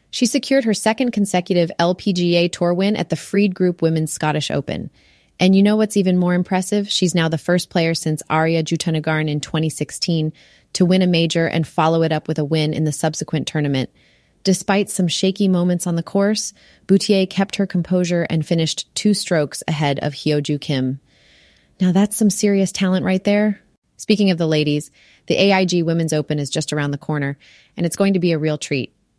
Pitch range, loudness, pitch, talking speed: 155-195 Hz, -19 LUFS, 170 Hz, 195 wpm